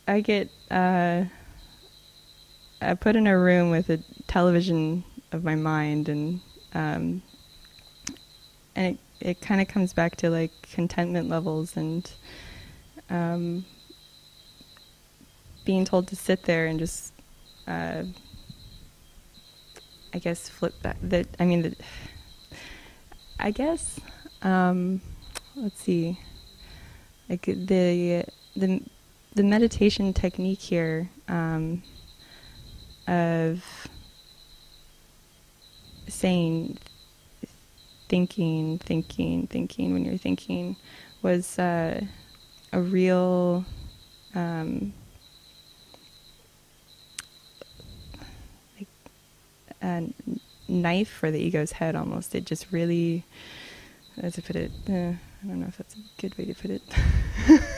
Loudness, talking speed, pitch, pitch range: -27 LUFS, 105 wpm, 175 Hz, 160-185 Hz